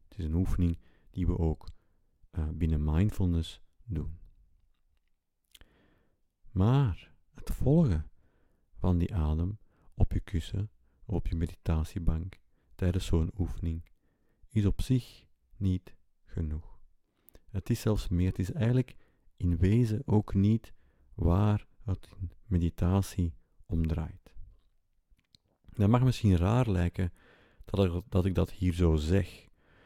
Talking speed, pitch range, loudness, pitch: 115 wpm, 85-100 Hz, -31 LUFS, 90 Hz